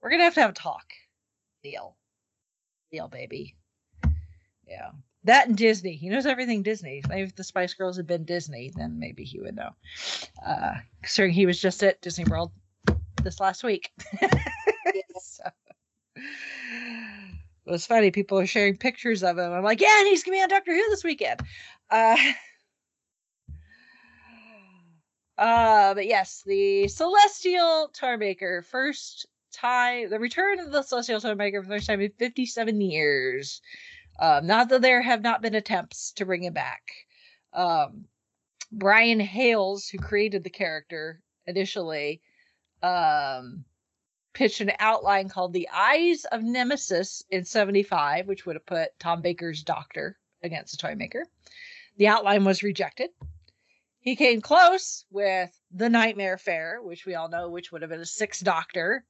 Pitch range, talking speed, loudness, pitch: 180-250 Hz, 155 wpm, -24 LUFS, 205 Hz